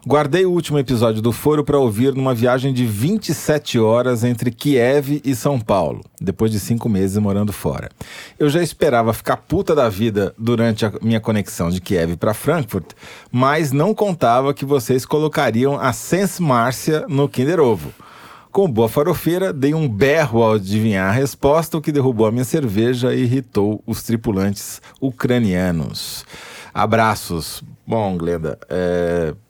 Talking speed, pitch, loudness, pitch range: 155 wpm, 125 Hz, -18 LUFS, 110-145 Hz